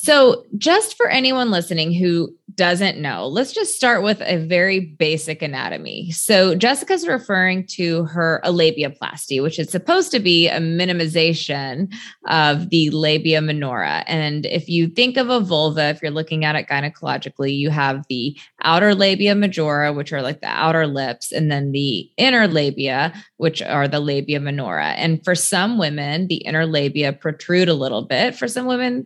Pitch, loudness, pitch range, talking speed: 165 Hz, -18 LUFS, 150-195 Hz, 170 wpm